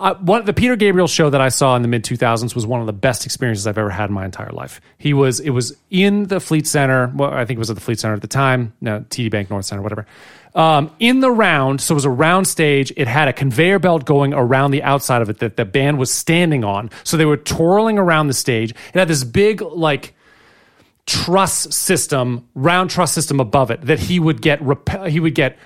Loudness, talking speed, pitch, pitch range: -16 LUFS, 255 wpm, 140 Hz, 120-165 Hz